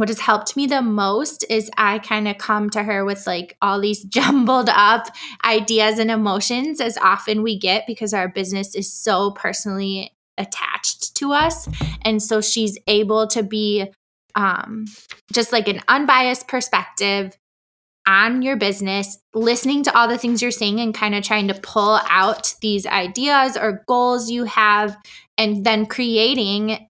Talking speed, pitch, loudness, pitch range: 165 wpm, 215 Hz, -18 LUFS, 200-235 Hz